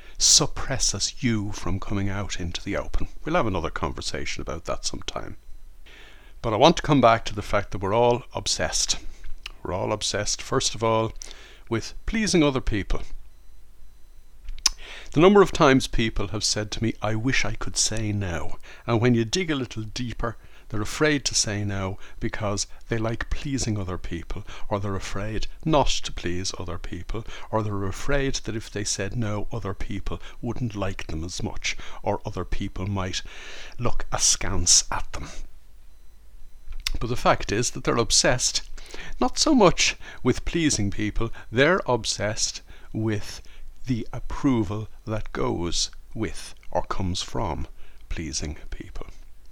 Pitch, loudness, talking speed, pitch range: 105 Hz, -25 LUFS, 155 wpm, 90-115 Hz